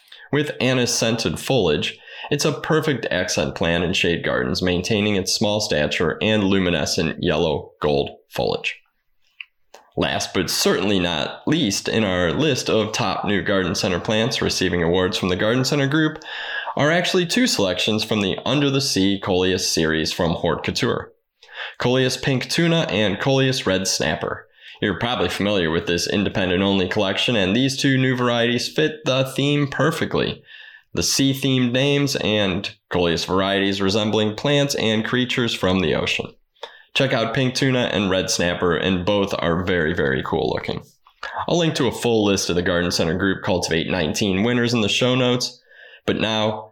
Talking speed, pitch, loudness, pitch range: 165 wpm, 110 Hz, -20 LUFS, 95-135 Hz